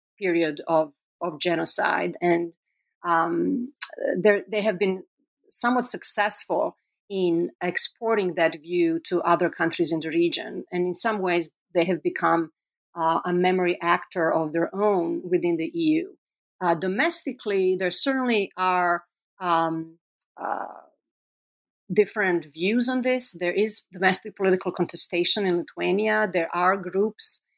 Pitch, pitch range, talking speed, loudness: 185 Hz, 170-215 Hz, 130 wpm, -23 LUFS